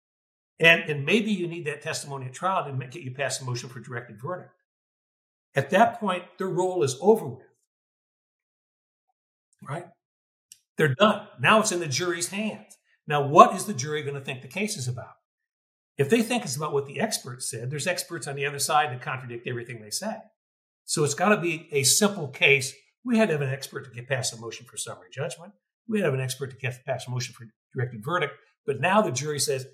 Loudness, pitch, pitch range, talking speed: -25 LUFS, 145 Hz, 130-180 Hz, 220 wpm